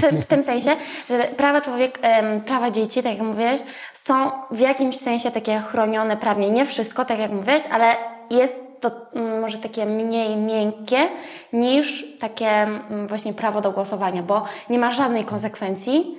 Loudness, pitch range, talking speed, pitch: -21 LUFS, 215-260 Hz, 150 wpm, 230 Hz